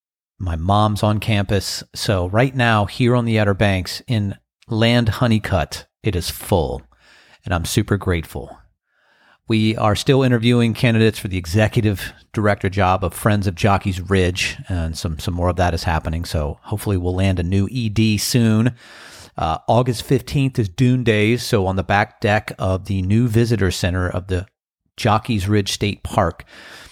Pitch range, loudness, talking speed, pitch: 90-115 Hz, -19 LUFS, 165 wpm, 105 Hz